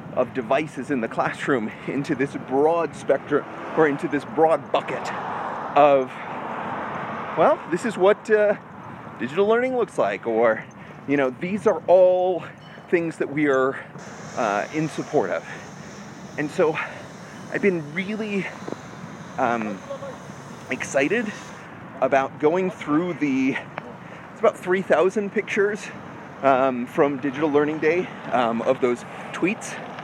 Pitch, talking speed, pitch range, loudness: 175 Hz, 125 wpm, 145-200 Hz, -23 LUFS